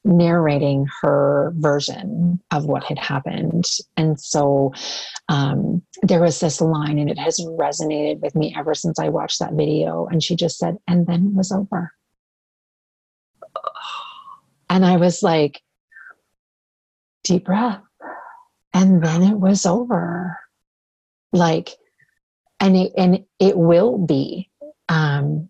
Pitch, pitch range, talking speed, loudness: 175 Hz, 150-190 Hz, 125 wpm, -19 LUFS